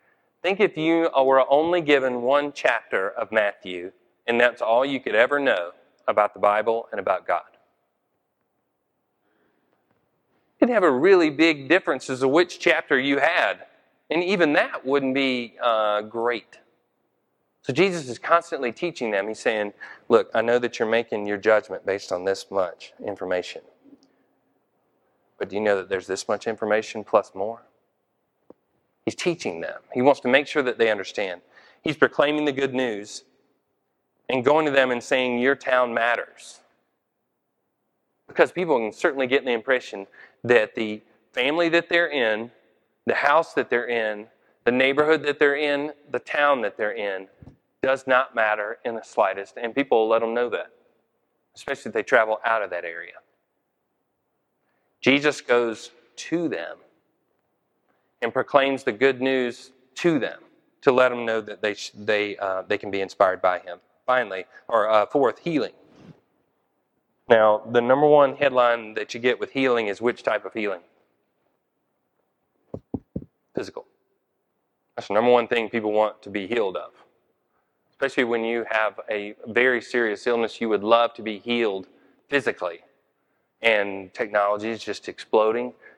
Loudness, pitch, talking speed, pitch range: -23 LUFS, 120 Hz, 160 wpm, 105-135 Hz